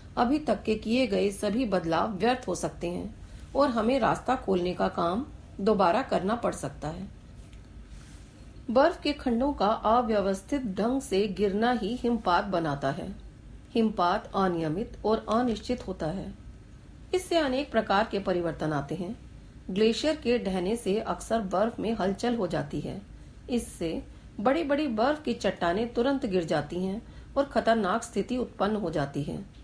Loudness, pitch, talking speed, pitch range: -28 LUFS, 220 Hz, 150 wpm, 185-245 Hz